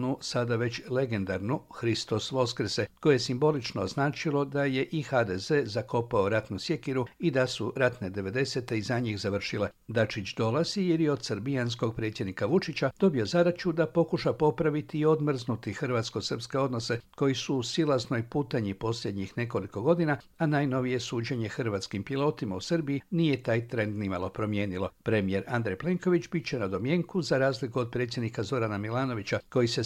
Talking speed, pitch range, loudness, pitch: 155 wpm, 110-145 Hz, -29 LUFS, 125 Hz